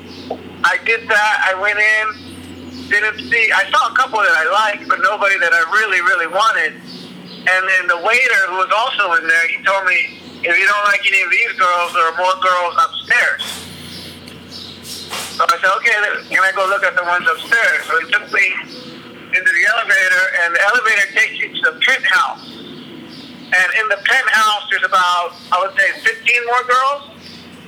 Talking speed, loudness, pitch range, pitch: 185 wpm, -14 LUFS, 175-240 Hz, 205 Hz